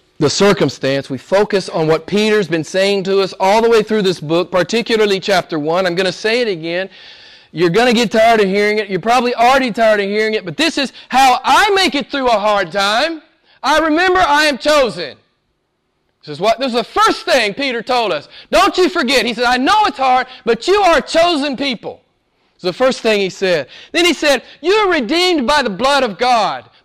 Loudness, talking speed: -14 LUFS, 215 wpm